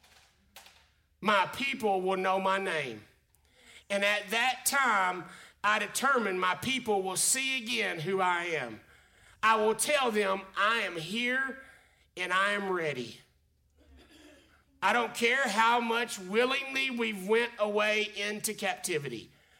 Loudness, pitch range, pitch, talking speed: -29 LUFS, 185-235 Hz, 205 Hz, 130 wpm